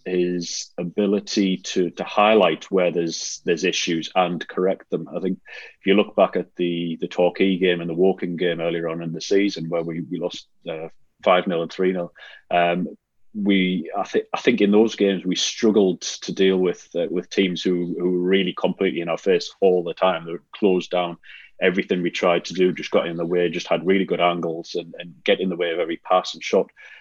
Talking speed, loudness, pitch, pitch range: 220 wpm, -22 LUFS, 90 Hz, 85-95 Hz